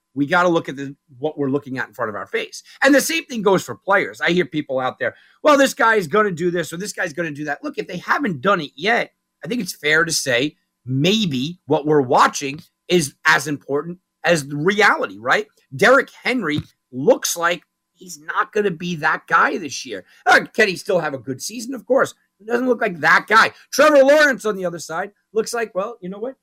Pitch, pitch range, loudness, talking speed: 175 Hz, 155-225 Hz, -19 LUFS, 245 wpm